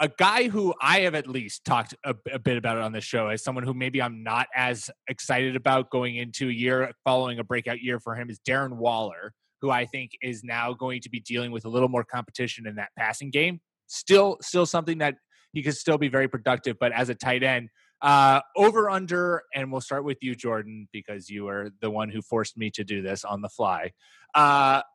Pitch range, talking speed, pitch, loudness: 115-140 Hz, 225 wpm, 125 Hz, -25 LUFS